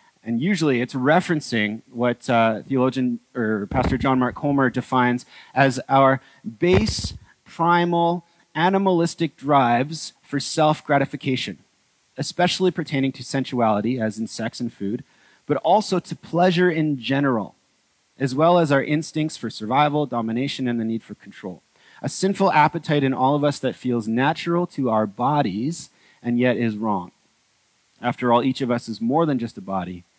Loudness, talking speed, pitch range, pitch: -21 LUFS, 155 wpm, 120-155 Hz, 135 Hz